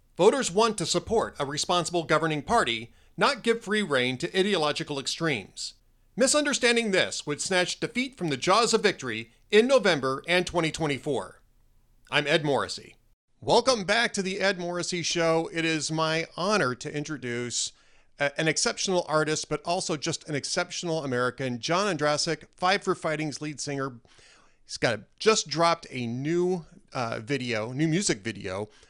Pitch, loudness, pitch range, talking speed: 165 Hz, -26 LUFS, 140-185 Hz, 150 wpm